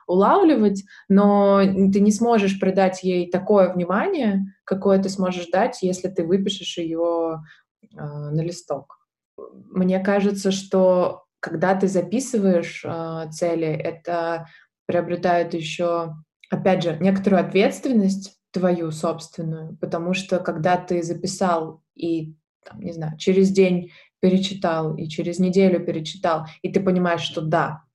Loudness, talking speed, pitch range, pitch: -21 LUFS, 125 wpm, 170-195 Hz, 180 Hz